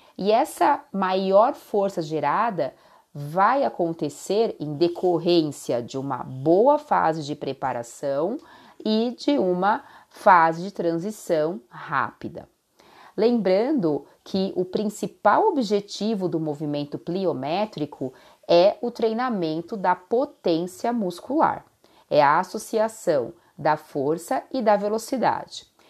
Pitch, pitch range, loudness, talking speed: 185 Hz, 160-225 Hz, -23 LUFS, 100 wpm